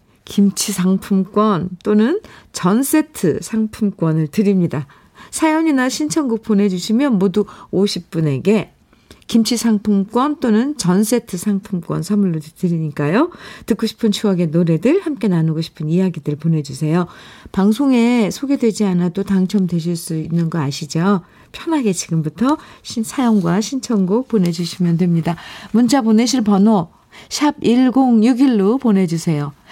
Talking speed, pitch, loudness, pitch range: 280 characters per minute, 205 Hz, -17 LUFS, 175-230 Hz